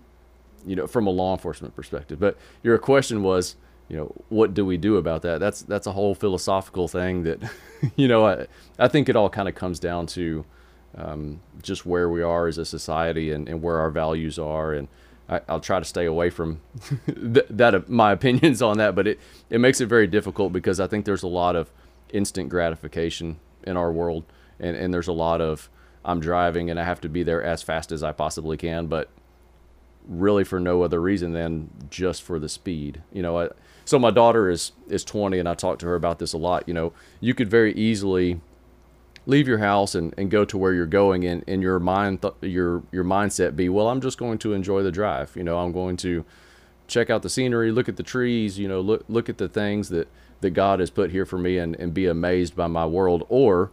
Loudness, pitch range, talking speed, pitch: -23 LUFS, 80-100 Hz, 230 wpm, 90 Hz